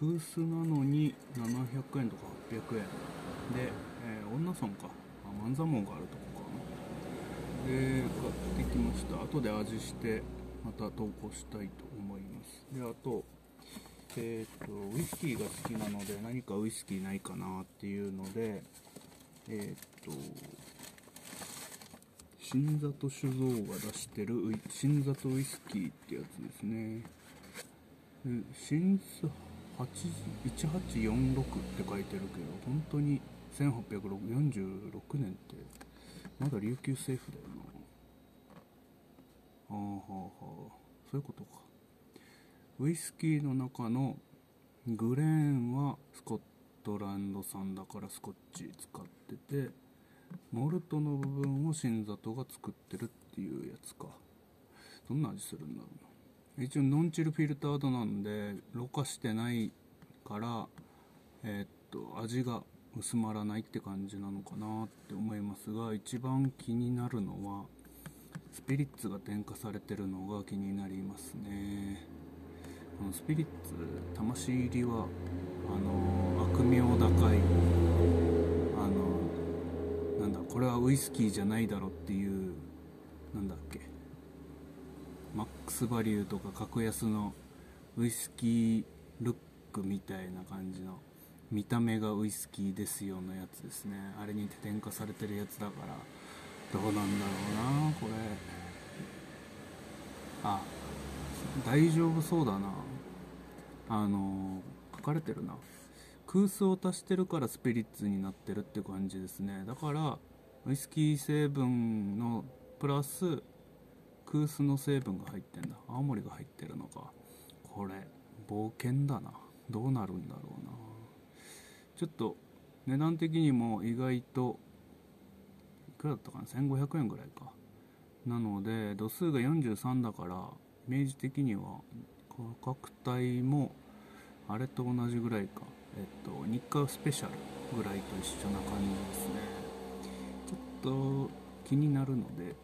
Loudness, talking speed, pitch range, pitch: -36 LUFS, 235 characters per minute, 95-135 Hz, 110 Hz